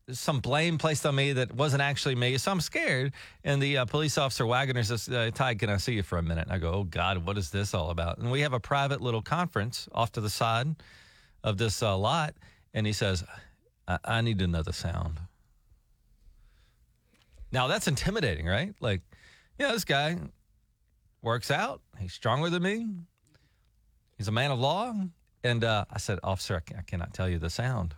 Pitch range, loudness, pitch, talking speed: 100-140 Hz, -29 LUFS, 115 Hz, 205 wpm